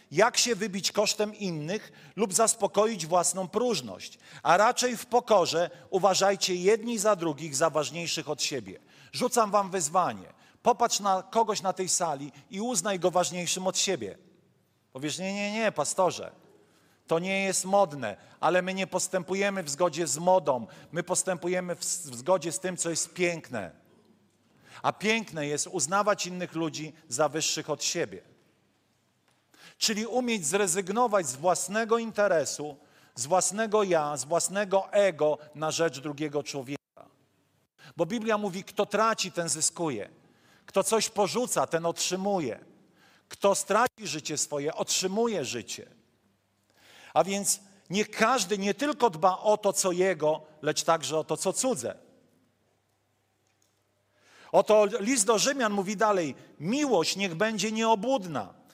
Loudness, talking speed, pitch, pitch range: -27 LUFS, 135 wpm, 185 Hz, 160-210 Hz